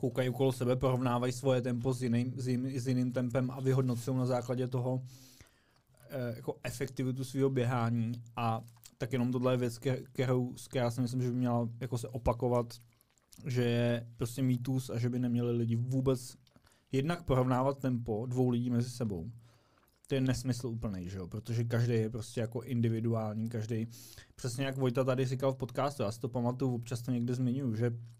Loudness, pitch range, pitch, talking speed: -34 LUFS, 120-130 Hz, 125 Hz, 180 wpm